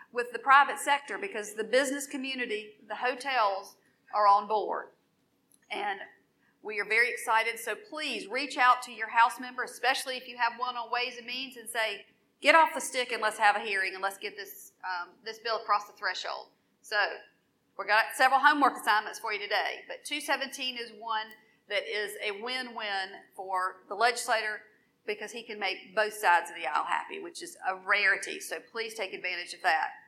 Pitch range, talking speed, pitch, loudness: 205-255 Hz, 195 wpm, 225 Hz, -29 LUFS